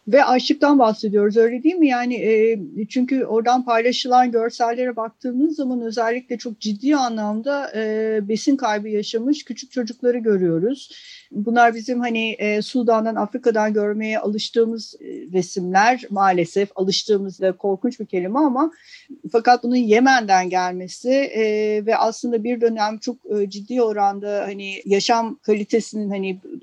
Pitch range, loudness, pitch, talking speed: 210-250 Hz, -20 LUFS, 230 Hz, 135 wpm